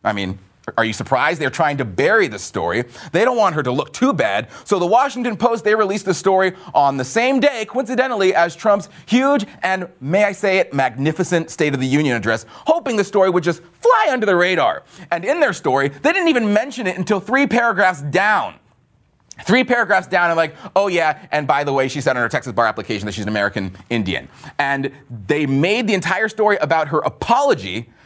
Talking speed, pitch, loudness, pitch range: 215 wpm, 175 Hz, -18 LUFS, 140-215 Hz